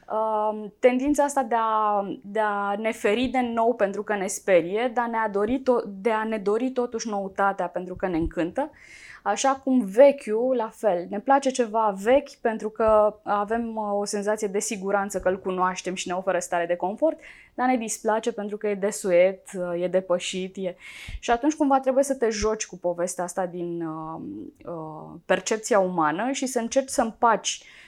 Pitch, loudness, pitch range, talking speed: 215 Hz, -25 LUFS, 190-245 Hz, 175 wpm